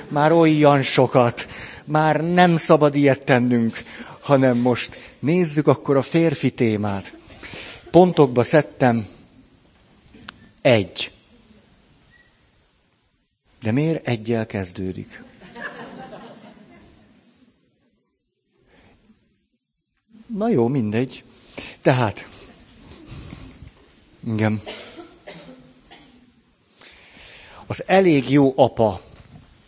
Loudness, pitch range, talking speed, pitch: -19 LUFS, 115-155 Hz, 65 wpm, 130 Hz